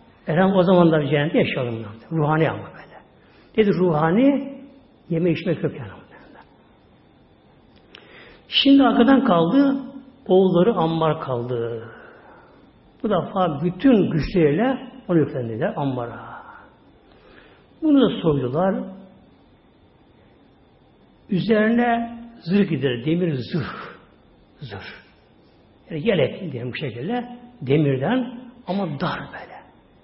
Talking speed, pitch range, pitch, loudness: 90 wpm, 150-240 Hz, 180 Hz, -20 LUFS